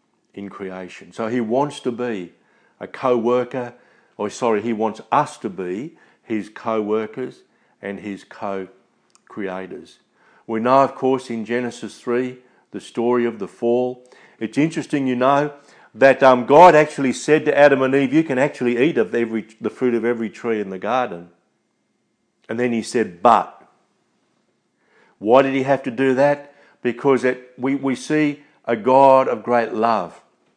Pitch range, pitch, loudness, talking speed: 115-135 Hz, 125 Hz, -19 LUFS, 165 wpm